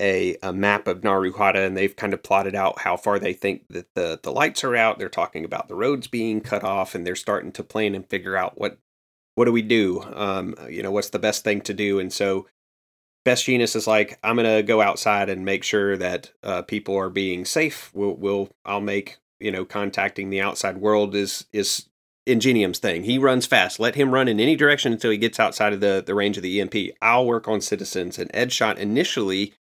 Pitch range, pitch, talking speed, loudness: 95-110 Hz, 100 Hz, 225 wpm, -22 LUFS